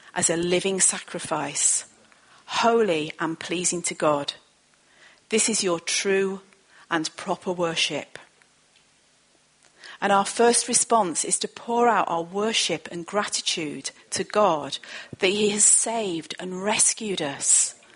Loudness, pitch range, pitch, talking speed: -23 LUFS, 170-215 Hz, 195 Hz, 125 wpm